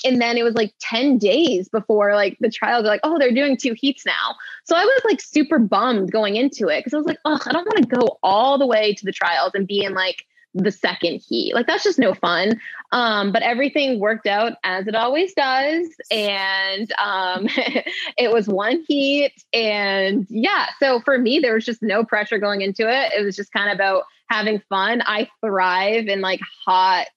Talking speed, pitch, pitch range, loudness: 210 wpm, 225 Hz, 205-270 Hz, -19 LUFS